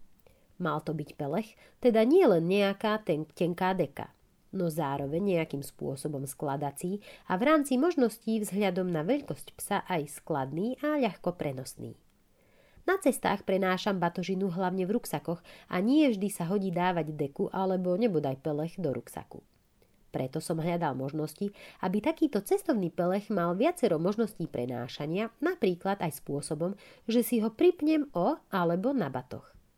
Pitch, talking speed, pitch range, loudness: 185 Hz, 140 wpm, 160-225 Hz, -30 LUFS